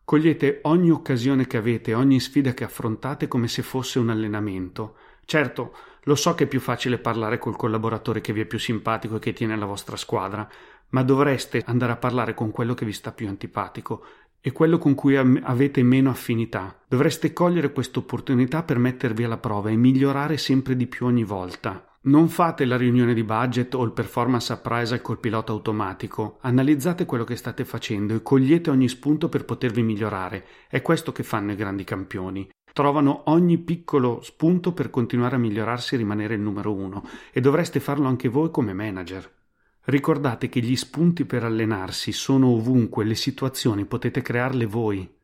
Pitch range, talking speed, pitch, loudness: 110-135 Hz, 175 wpm, 125 Hz, -23 LUFS